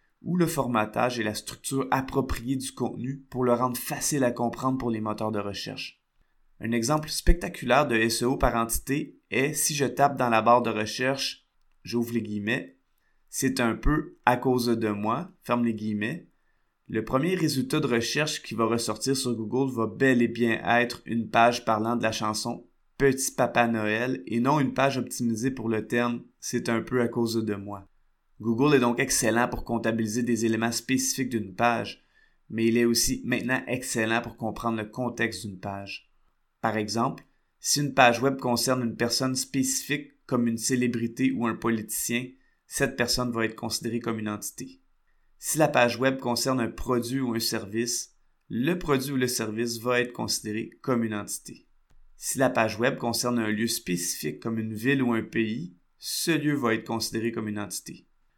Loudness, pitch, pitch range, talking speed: -27 LUFS, 120 Hz, 115-130 Hz, 185 wpm